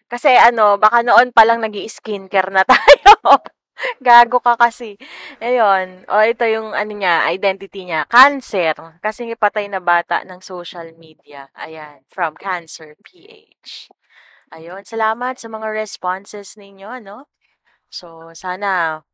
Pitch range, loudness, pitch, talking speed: 180-235 Hz, -14 LUFS, 205 Hz, 130 wpm